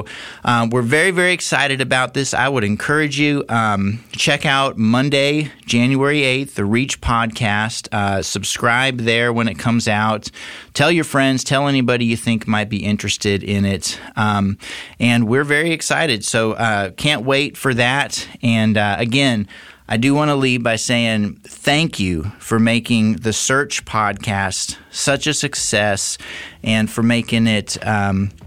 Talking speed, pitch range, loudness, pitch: 160 wpm, 105-135 Hz, -17 LUFS, 115 Hz